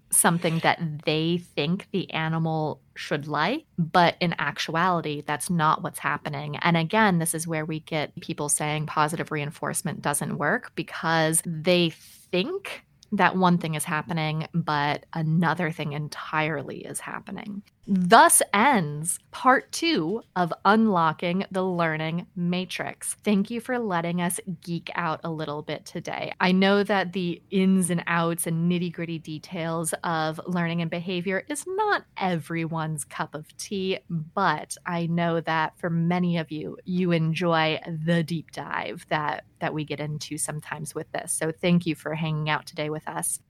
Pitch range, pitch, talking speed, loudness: 155-180 Hz, 170 Hz, 155 wpm, -25 LUFS